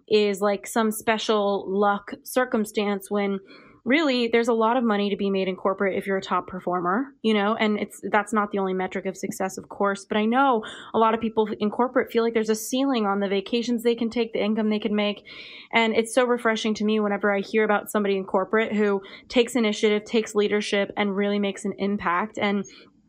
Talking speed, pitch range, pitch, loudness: 220 wpm, 200-230 Hz, 210 Hz, -24 LUFS